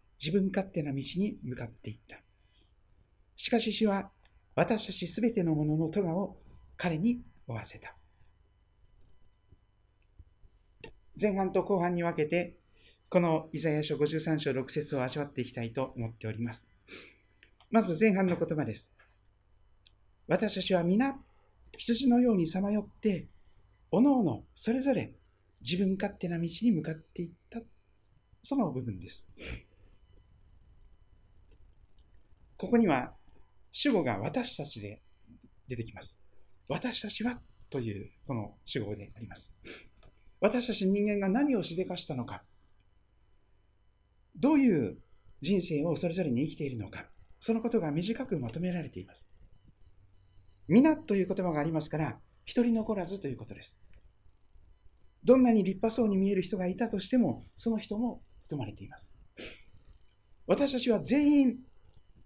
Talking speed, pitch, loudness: 255 characters per minute, 140 Hz, -31 LUFS